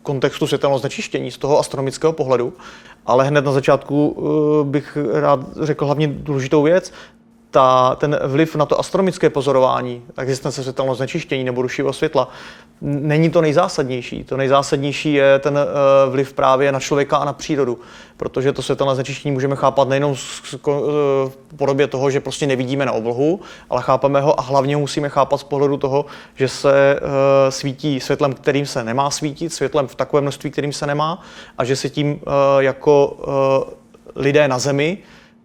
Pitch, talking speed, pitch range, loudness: 140 Hz, 155 wpm, 135-150 Hz, -18 LUFS